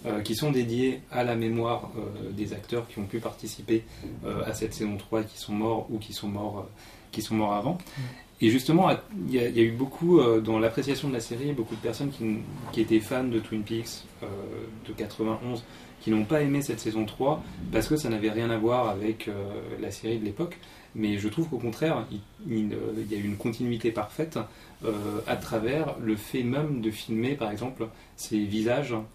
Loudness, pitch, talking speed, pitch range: -29 LUFS, 110 Hz, 210 wpm, 110-125 Hz